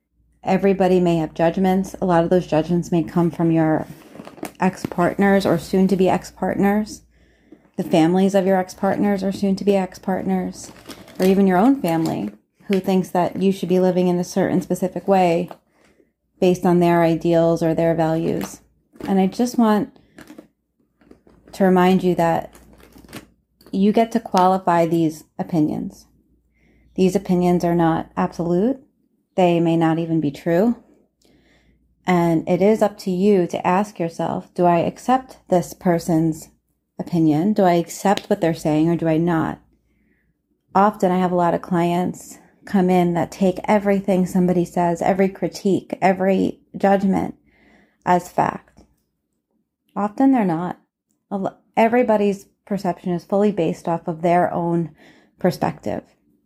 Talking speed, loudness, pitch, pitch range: 140 wpm, -19 LUFS, 180 Hz, 170-195 Hz